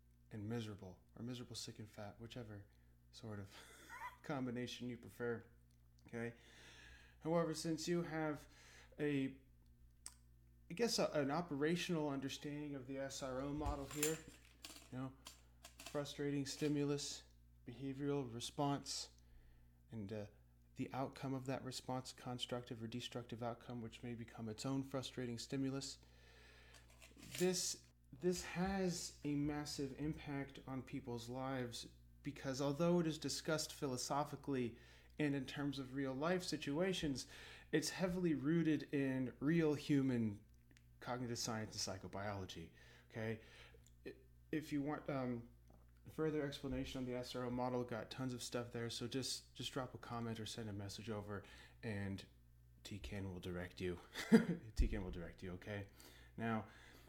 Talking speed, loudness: 130 wpm, -44 LUFS